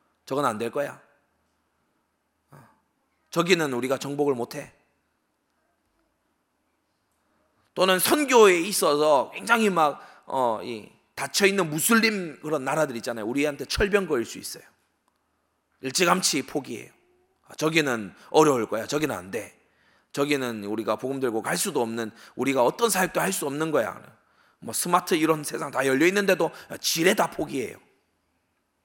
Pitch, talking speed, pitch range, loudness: 145 Hz, 270 characters per minute, 120-185 Hz, -24 LUFS